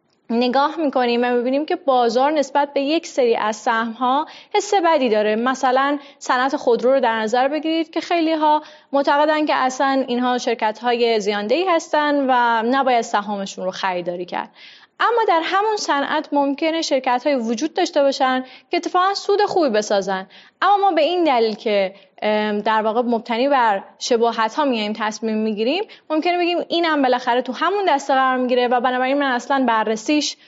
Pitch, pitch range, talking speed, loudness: 265 Hz, 235-305 Hz, 165 wpm, -19 LUFS